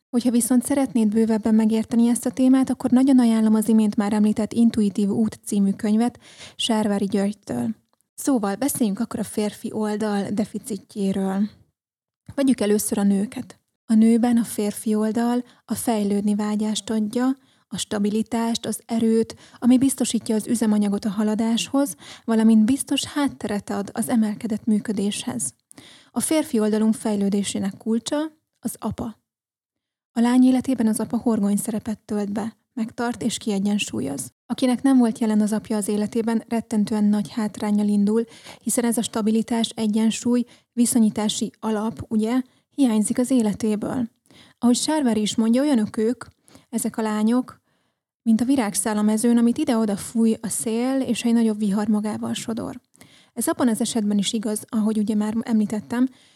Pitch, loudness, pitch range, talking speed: 225 Hz, -22 LUFS, 215-240 Hz, 145 wpm